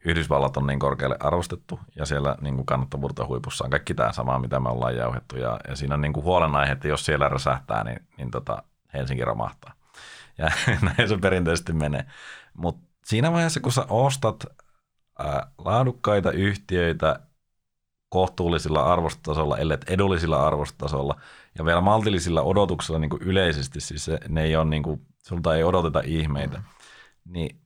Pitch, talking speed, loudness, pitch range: 80 Hz, 135 wpm, -25 LUFS, 70-95 Hz